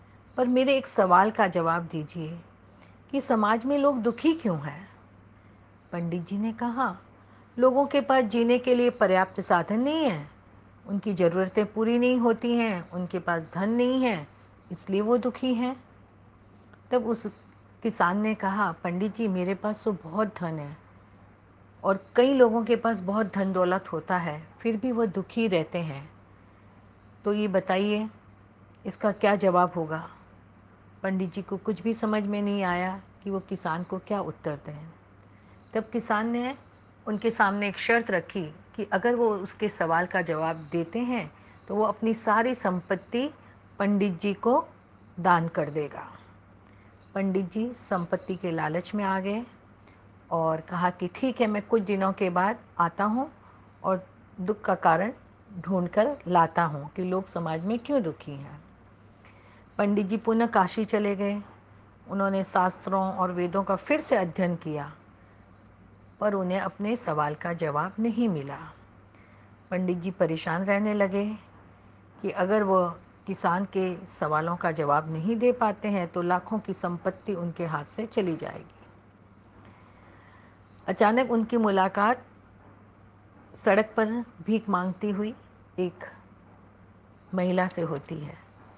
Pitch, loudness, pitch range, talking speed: 185 Hz, -27 LUFS, 145-215 Hz, 150 wpm